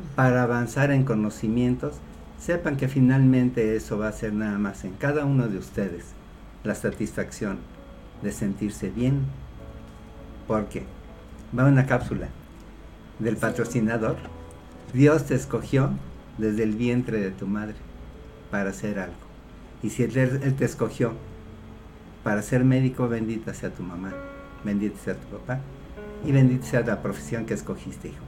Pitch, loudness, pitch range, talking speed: 110 Hz, -25 LUFS, 100-130 Hz, 140 wpm